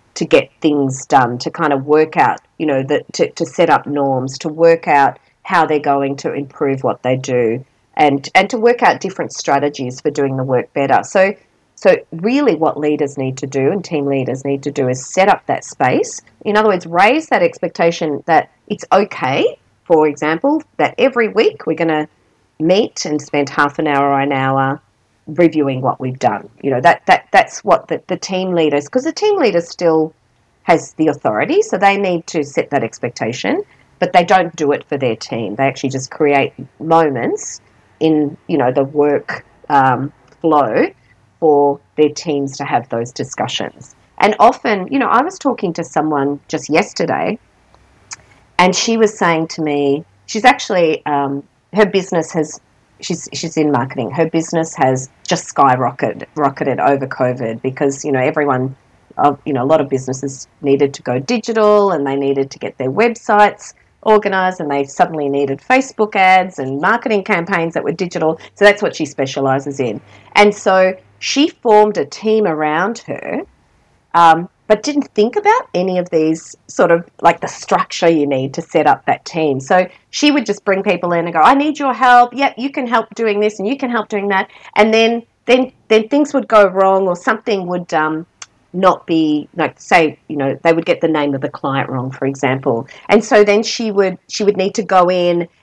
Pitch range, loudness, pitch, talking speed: 140-200 Hz, -15 LUFS, 160 Hz, 195 wpm